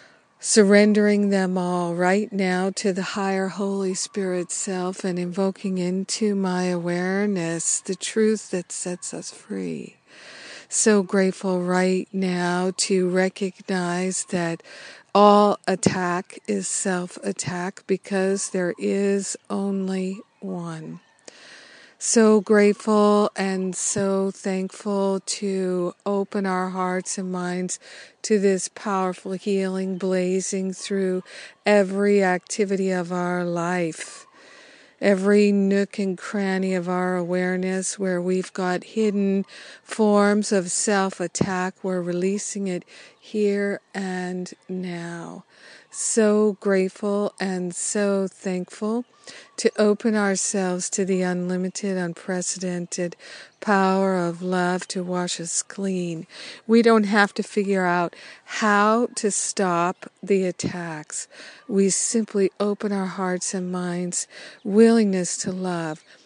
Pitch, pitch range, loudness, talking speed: 190 Hz, 180-205 Hz, -23 LUFS, 110 wpm